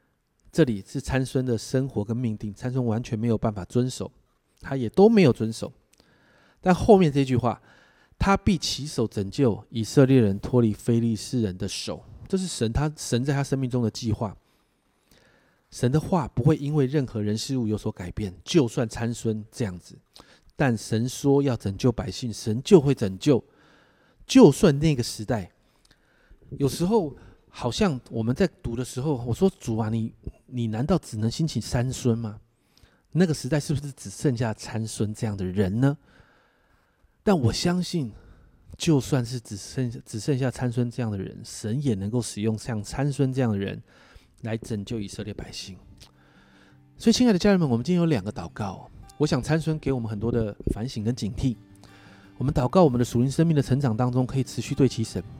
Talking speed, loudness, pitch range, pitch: 265 characters per minute, -25 LUFS, 110-140 Hz, 120 Hz